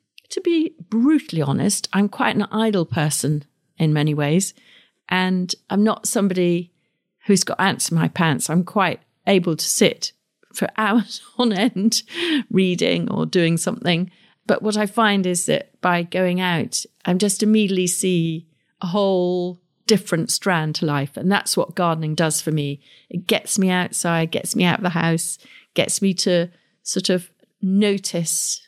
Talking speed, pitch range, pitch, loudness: 165 wpm, 170-210 Hz, 185 Hz, -20 LUFS